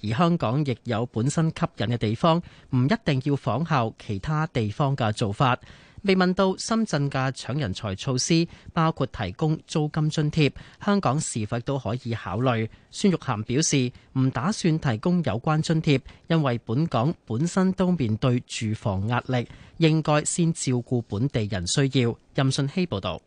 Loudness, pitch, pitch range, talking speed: -25 LUFS, 135 Hz, 120-160 Hz, 245 characters per minute